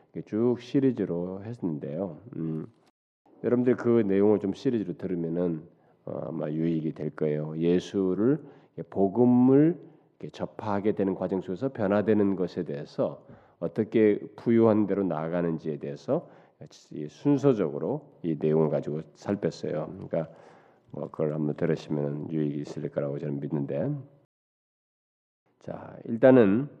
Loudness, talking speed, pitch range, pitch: -27 LUFS, 280 characters per minute, 80-115 Hz, 95 Hz